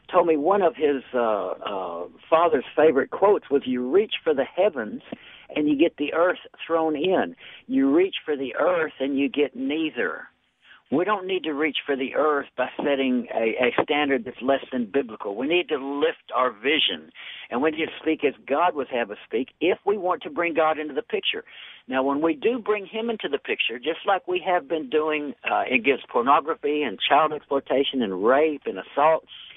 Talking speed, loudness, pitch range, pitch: 205 wpm, -24 LUFS, 140-195 Hz, 155 Hz